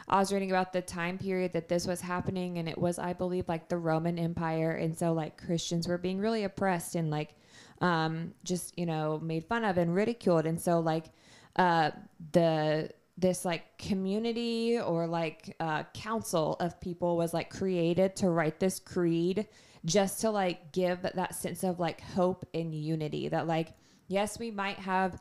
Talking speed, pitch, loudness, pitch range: 185 wpm, 175 Hz, -32 LUFS, 165-190 Hz